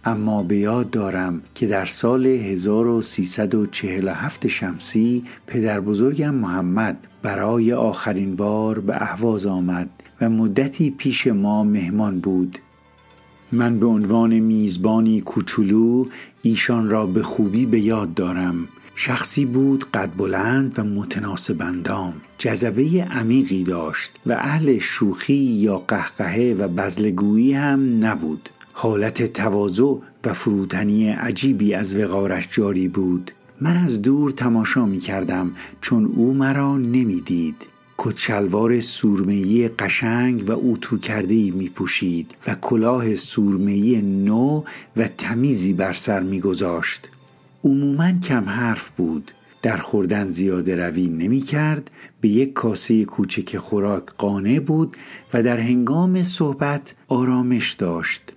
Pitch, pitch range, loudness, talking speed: 110 Hz, 100-125 Hz, -20 LUFS, 120 wpm